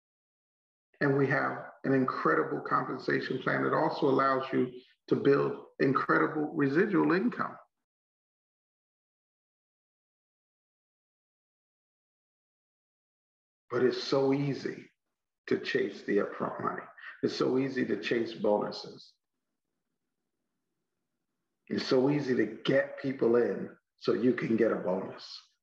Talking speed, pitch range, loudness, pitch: 105 wpm, 125-140 Hz, -30 LUFS, 135 Hz